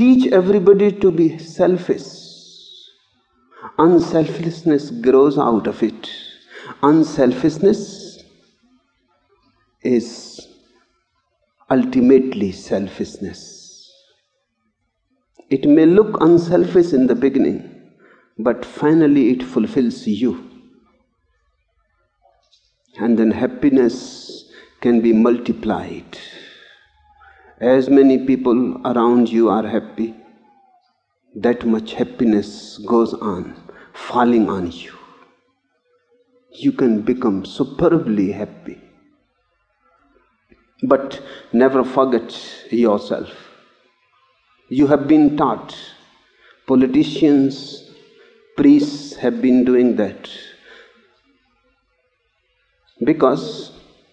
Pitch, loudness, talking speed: 145 Hz, -16 LUFS, 75 wpm